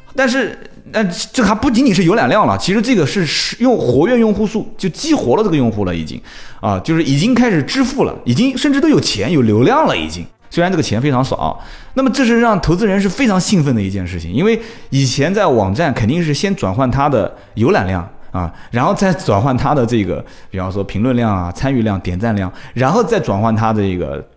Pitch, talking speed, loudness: 150 Hz, 330 characters per minute, -15 LUFS